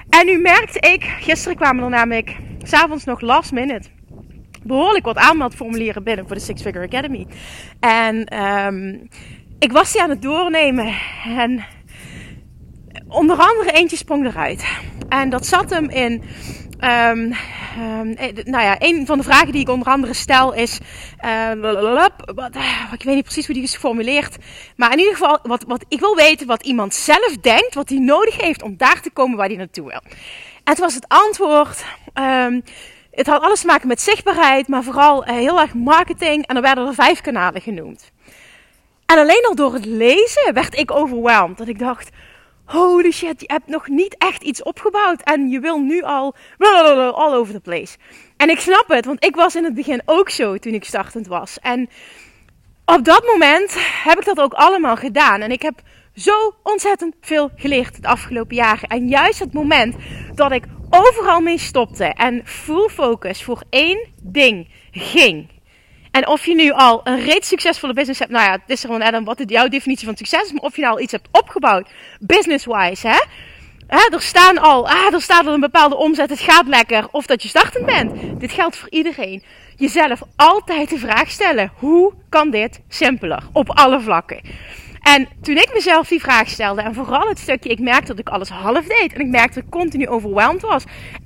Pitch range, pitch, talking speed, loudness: 240-330 Hz, 280 Hz, 195 wpm, -14 LUFS